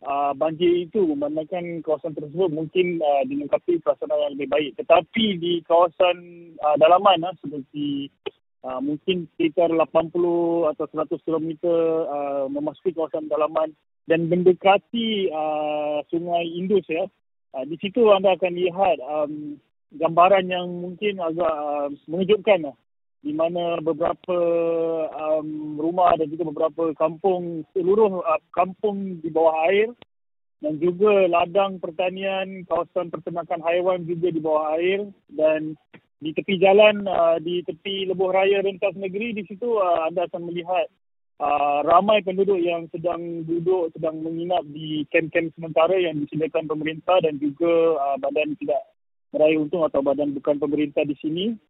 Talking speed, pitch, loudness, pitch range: 140 wpm, 170 Hz, -22 LUFS, 155-185 Hz